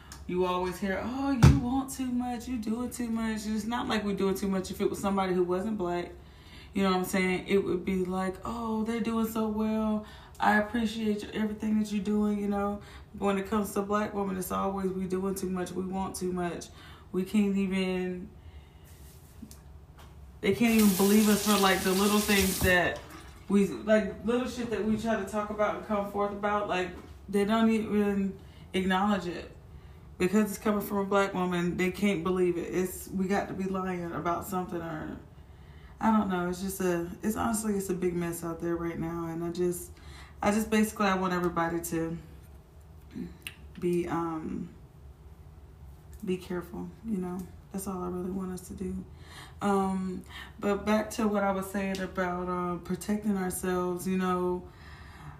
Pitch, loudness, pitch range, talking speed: 190 Hz, -30 LUFS, 175-210 Hz, 190 wpm